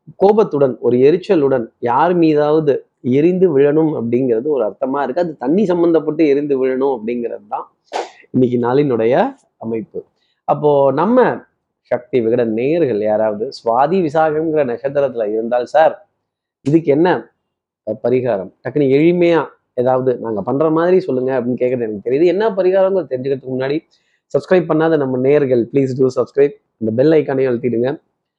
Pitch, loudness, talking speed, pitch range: 140 Hz, -16 LUFS, 130 wpm, 125-160 Hz